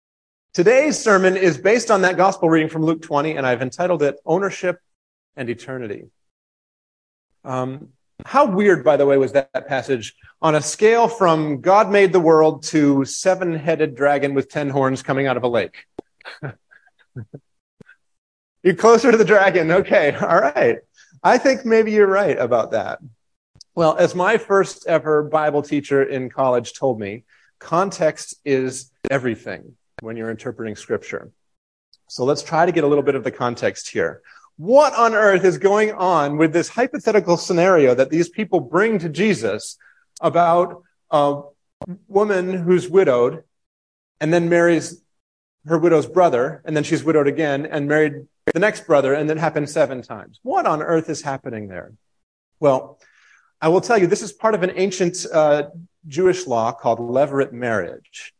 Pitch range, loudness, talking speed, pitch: 135-185 Hz, -18 LUFS, 160 wpm, 155 Hz